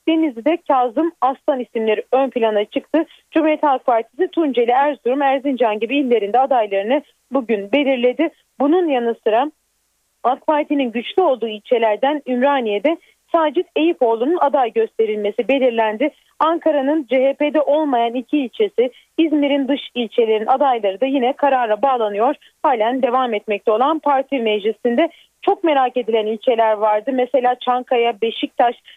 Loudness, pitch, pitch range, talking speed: -18 LUFS, 265 Hz, 235-295 Hz, 120 wpm